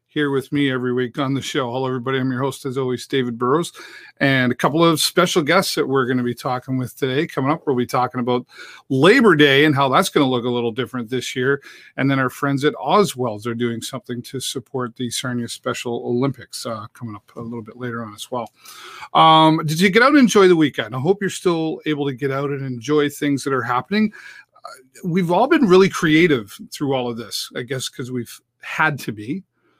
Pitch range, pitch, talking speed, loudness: 125-150 Hz, 135 Hz, 230 wpm, -19 LUFS